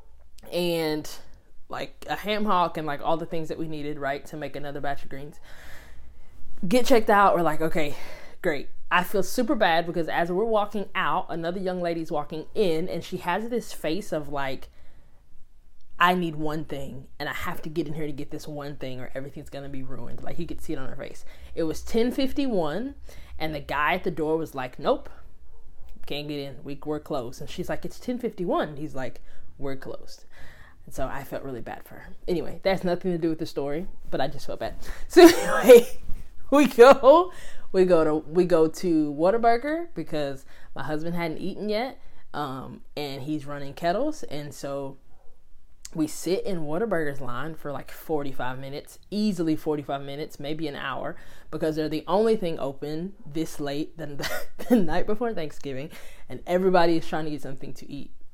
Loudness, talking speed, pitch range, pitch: -25 LUFS, 190 wpm, 145-180 Hz, 155 Hz